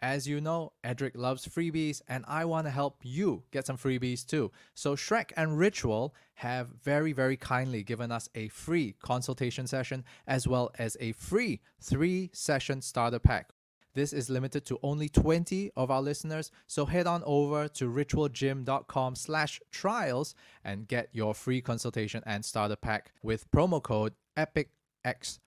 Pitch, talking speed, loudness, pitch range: 130 Hz, 160 wpm, -32 LUFS, 120-150 Hz